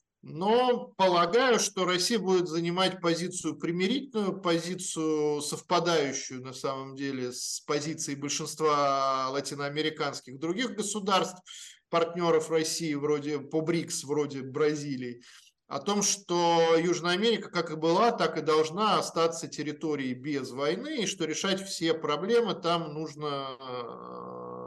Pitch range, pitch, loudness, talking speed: 145-180 Hz, 160 Hz, -29 LUFS, 115 wpm